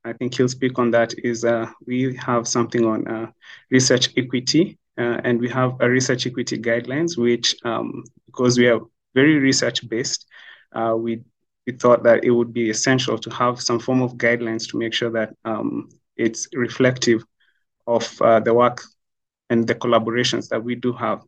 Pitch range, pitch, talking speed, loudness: 115-125 Hz, 120 Hz, 180 wpm, -20 LUFS